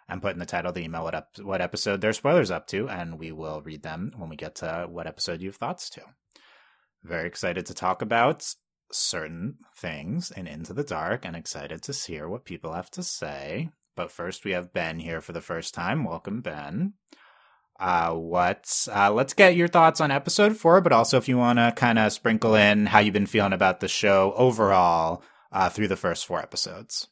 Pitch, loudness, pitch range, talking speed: 105 Hz, -24 LUFS, 90-135 Hz, 210 wpm